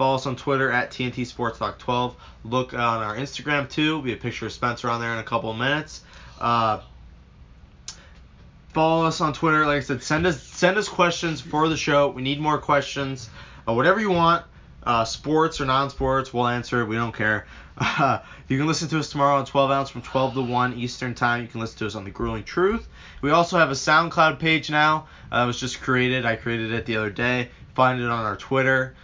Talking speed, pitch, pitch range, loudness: 225 wpm, 130 Hz, 115-150 Hz, -23 LUFS